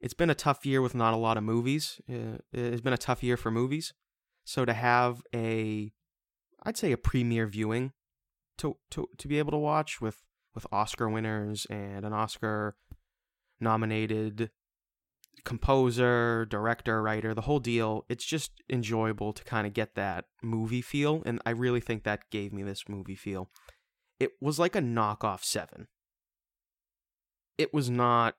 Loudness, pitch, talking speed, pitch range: -31 LUFS, 115 Hz, 165 wpm, 105-125 Hz